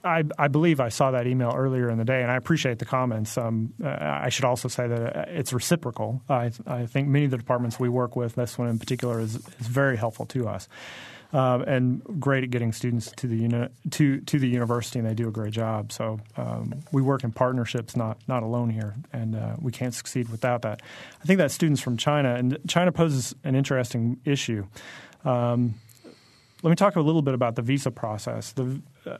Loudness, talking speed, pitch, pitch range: -26 LUFS, 215 wpm, 125 Hz, 115-135 Hz